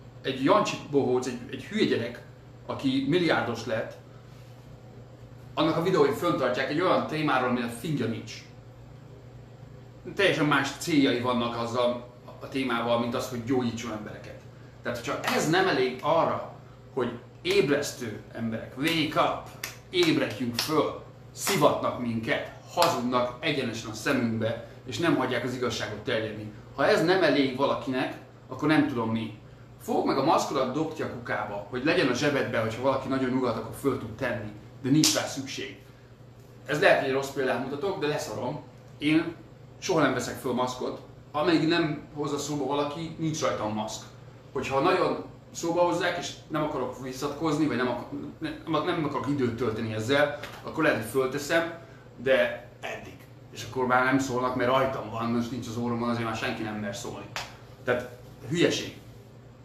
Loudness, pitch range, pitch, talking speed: -28 LUFS, 120-140 Hz, 125 Hz, 155 wpm